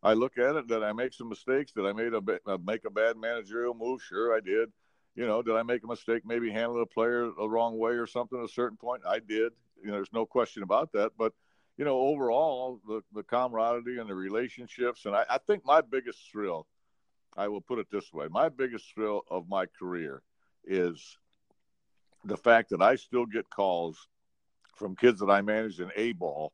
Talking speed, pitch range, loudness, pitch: 215 wpm, 105-120 Hz, -30 LUFS, 115 Hz